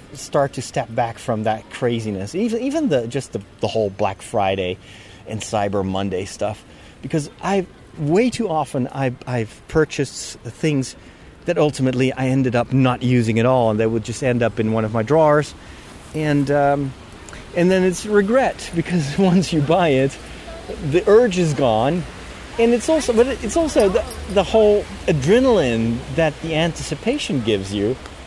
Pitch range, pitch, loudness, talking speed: 110-170 Hz, 135 Hz, -19 LUFS, 170 wpm